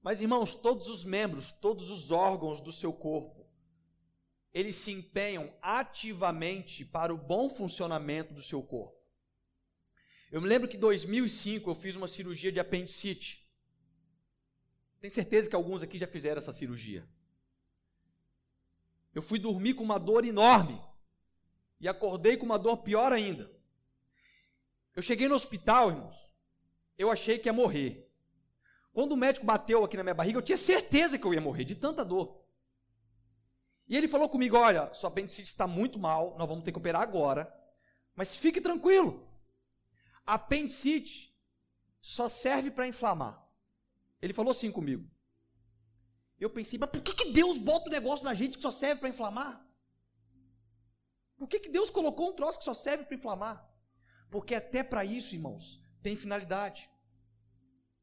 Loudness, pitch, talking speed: -31 LUFS, 190 Hz, 155 wpm